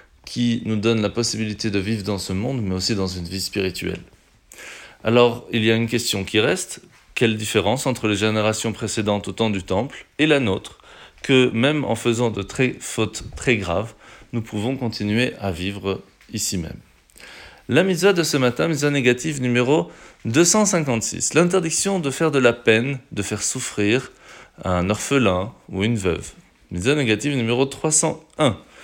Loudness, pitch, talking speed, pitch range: -21 LUFS, 115 Hz, 165 wpm, 105-130 Hz